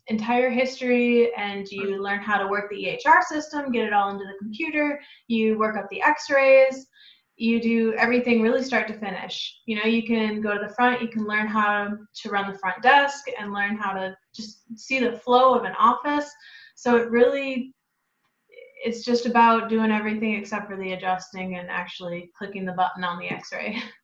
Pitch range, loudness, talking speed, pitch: 200-250 Hz, -23 LUFS, 195 wpm, 225 Hz